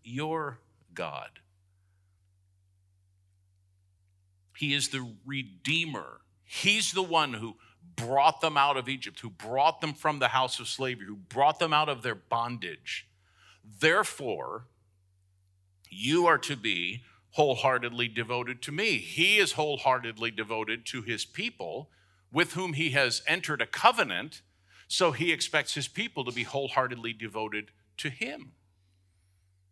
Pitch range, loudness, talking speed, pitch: 95-145 Hz, -28 LUFS, 130 wpm, 115 Hz